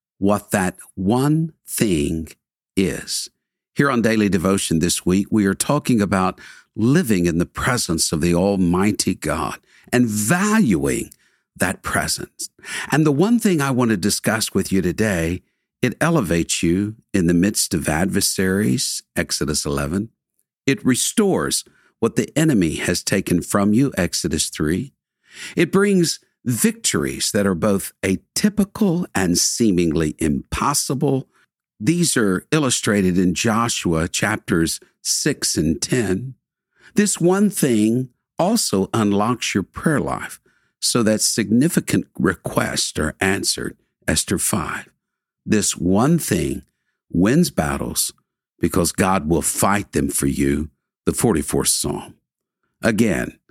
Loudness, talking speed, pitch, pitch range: -19 LUFS, 125 wpm, 105 Hz, 90-145 Hz